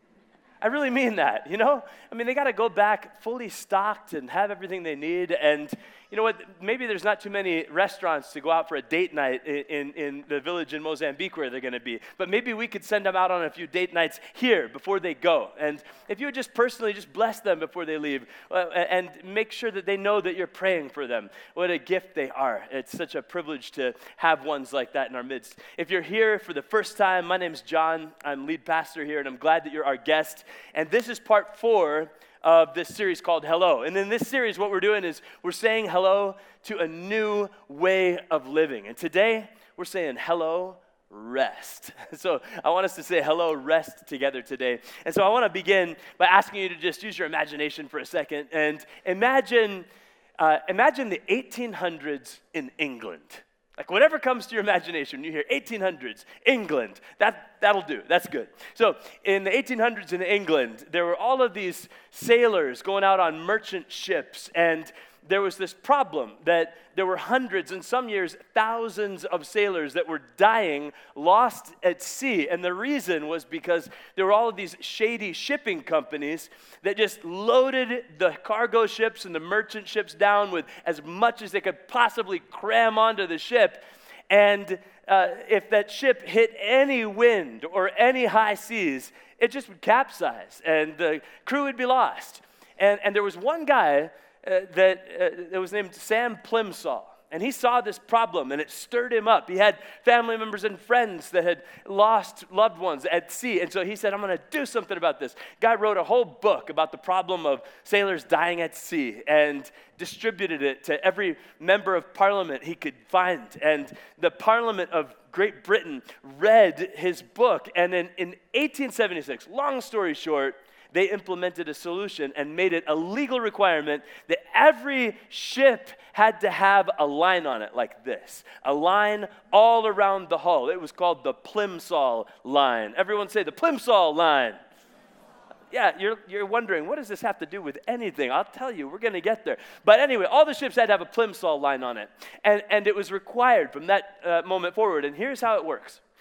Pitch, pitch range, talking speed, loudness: 195 Hz, 165-225 Hz, 200 wpm, -25 LUFS